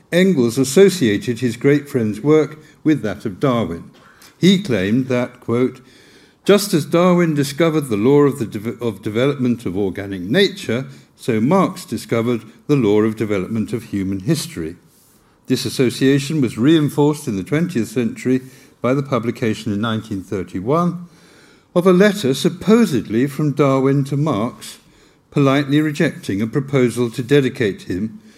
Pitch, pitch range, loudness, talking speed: 135 Hz, 115-155 Hz, -18 LUFS, 140 wpm